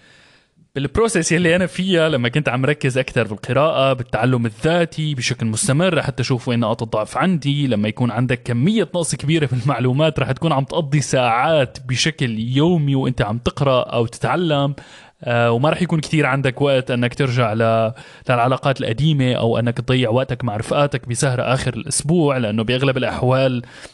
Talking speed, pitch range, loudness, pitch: 155 wpm, 125-150 Hz, -18 LUFS, 130 Hz